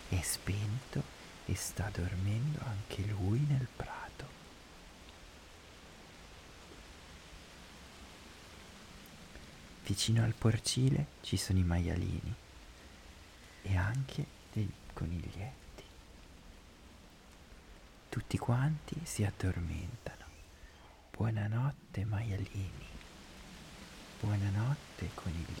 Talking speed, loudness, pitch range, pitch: 65 wpm, -37 LUFS, 80-105 Hz, 95 Hz